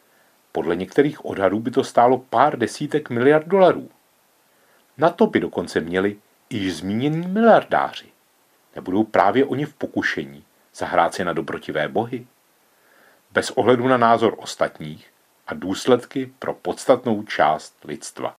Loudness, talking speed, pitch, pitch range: -20 LUFS, 130 wpm, 130 Hz, 110-150 Hz